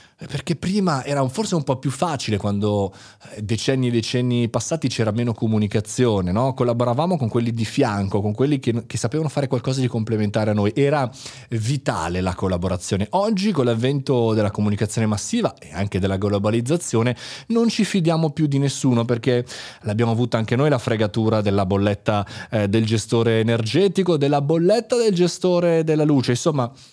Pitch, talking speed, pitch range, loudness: 120 Hz, 165 wpm, 110-145 Hz, -21 LUFS